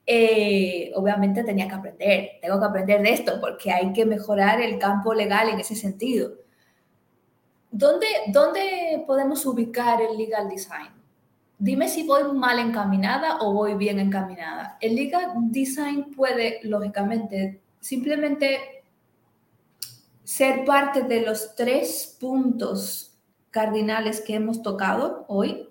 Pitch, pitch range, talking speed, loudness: 220 Hz, 200-260 Hz, 125 wpm, -23 LUFS